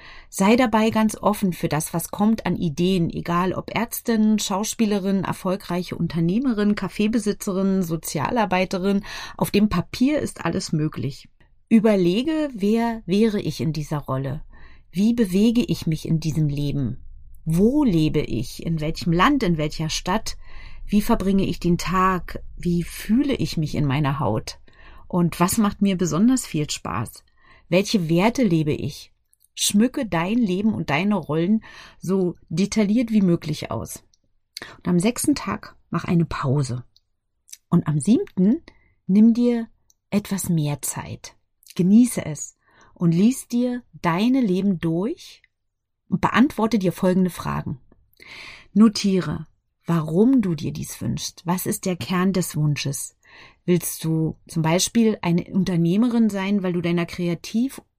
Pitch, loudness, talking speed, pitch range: 185 Hz, -22 LUFS, 135 wpm, 160-215 Hz